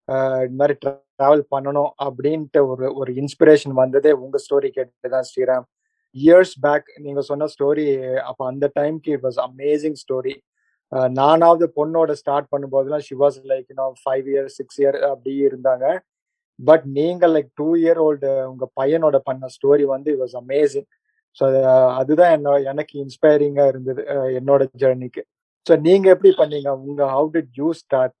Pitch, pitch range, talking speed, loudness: 140 Hz, 135-150 Hz, 140 wpm, -18 LUFS